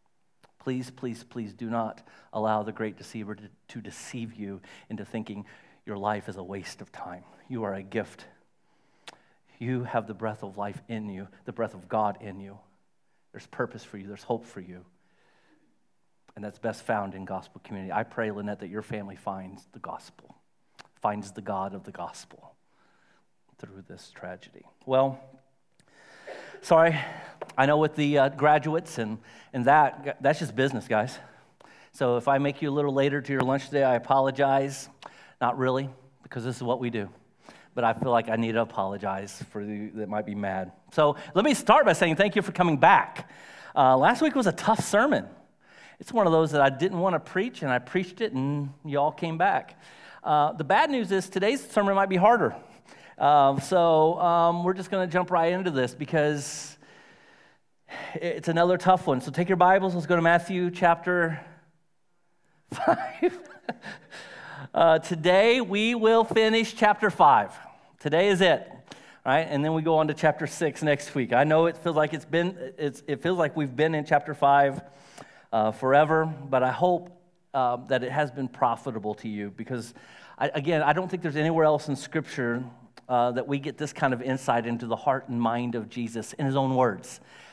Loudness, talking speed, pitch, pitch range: -25 LUFS, 190 wpm, 140 Hz, 115-165 Hz